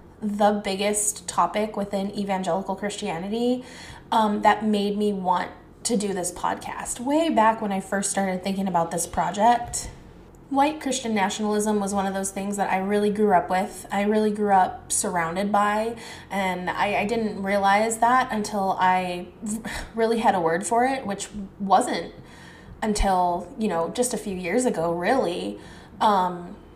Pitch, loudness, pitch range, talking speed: 205 Hz, -24 LUFS, 190-215 Hz, 160 wpm